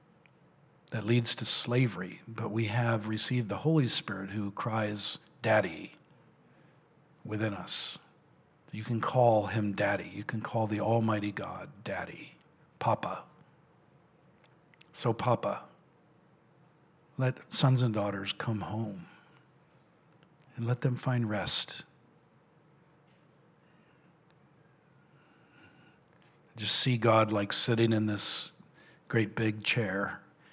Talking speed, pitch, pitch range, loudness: 100 wpm, 120 Hz, 110-155 Hz, -30 LUFS